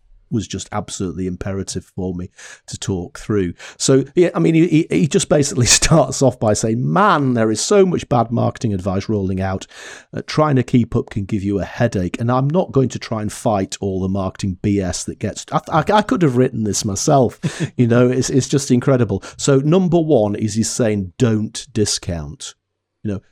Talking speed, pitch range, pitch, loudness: 205 wpm, 100-135 Hz, 115 Hz, -17 LUFS